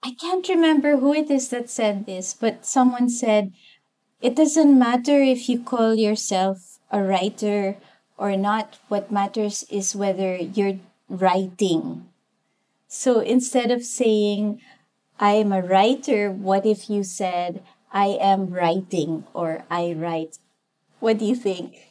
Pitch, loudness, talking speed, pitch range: 210 Hz, -22 LUFS, 135 wpm, 195-245 Hz